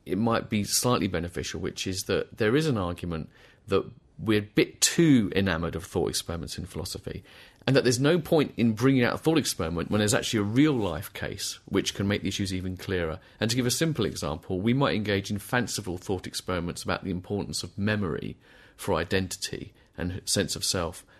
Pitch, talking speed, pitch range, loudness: 100 Hz, 205 wpm, 90-115 Hz, -27 LUFS